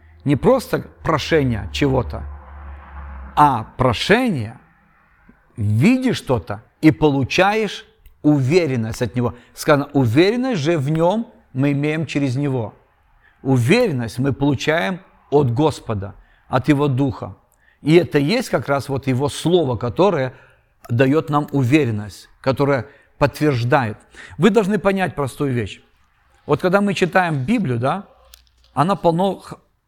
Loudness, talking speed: -19 LUFS, 115 wpm